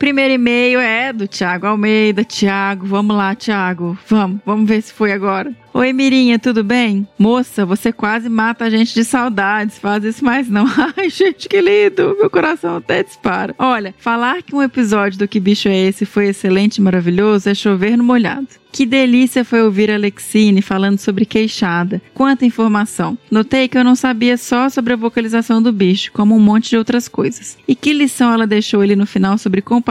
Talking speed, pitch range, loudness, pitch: 195 wpm, 205-250 Hz, -14 LUFS, 220 Hz